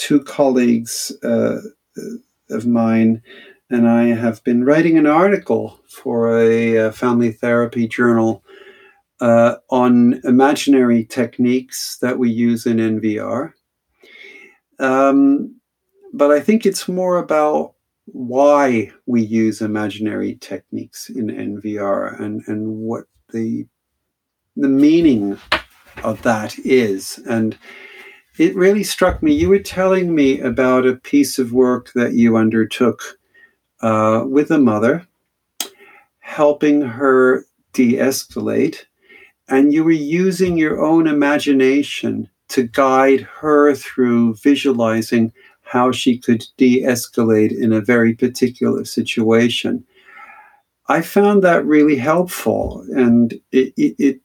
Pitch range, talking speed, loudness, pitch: 115-155 Hz, 115 wpm, -16 LUFS, 130 Hz